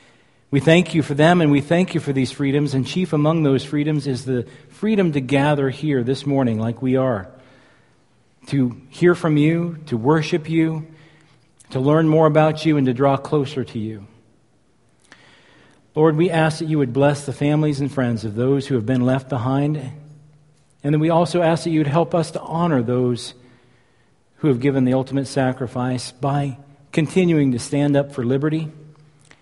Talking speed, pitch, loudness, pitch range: 185 wpm, 145 Hz, -19 LUFS, 130-155 Hz